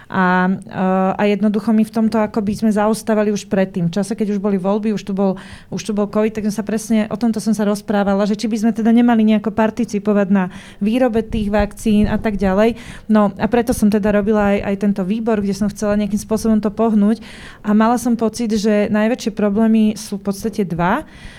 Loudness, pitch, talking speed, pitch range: -17 LUFS, 215 Hz, 215 wpm, 205-220 Hz